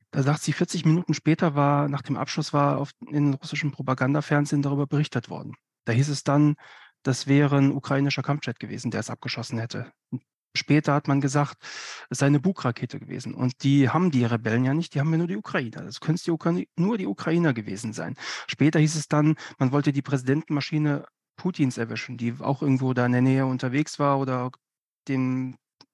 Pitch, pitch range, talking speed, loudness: 140 Hz, 130-150 Hz, 190 wpm, -25 LUFS